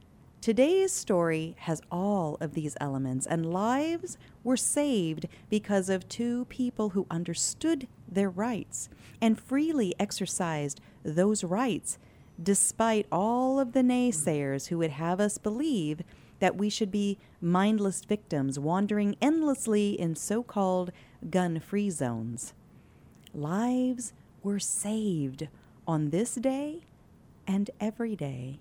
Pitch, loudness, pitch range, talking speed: 200 Hz, -30 LUFS, 165-235 Hz, 120 wpm